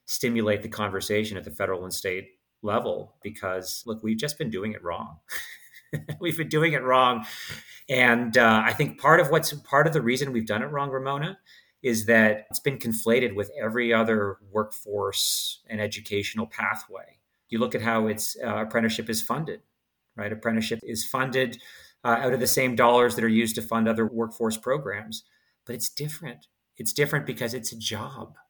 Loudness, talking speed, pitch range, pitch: -25 LUFS, 180 wpm, 110-130 Hz, 115 Hz